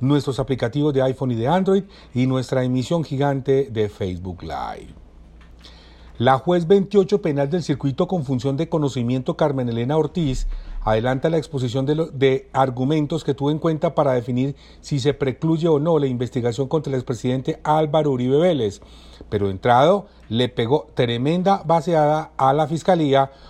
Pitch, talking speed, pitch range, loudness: 135 Hz, 160 wpm, 125-160 Hz, -21 LUFS